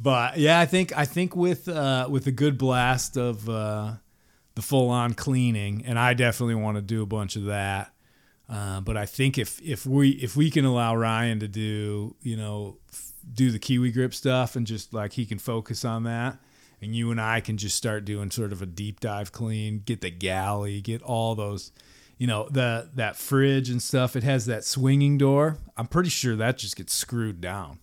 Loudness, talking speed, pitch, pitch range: -26 LUFS, 210 wpm, 115 Hz, 105-130 Hz